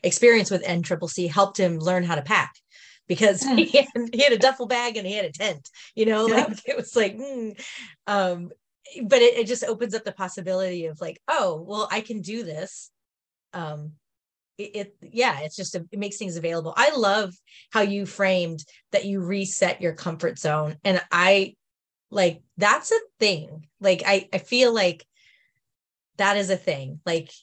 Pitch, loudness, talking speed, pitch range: 195 Hz, -23 LUFS, 185 wpm, 175-225 Hz